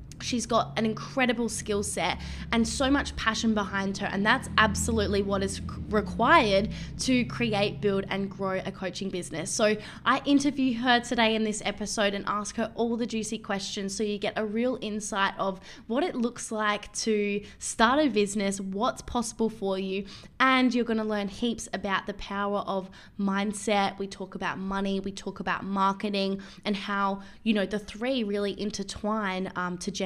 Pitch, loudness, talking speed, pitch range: 205 Hz, -28 LUFS, 180 wpm, 195-225 Hz